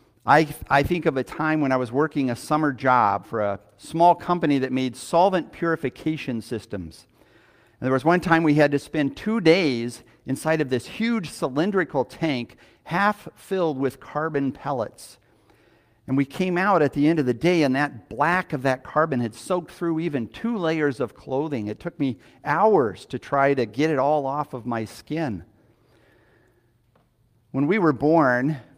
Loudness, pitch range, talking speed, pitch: -23 LUFS, 120-160 Hz, 180 wpm, 140 Hz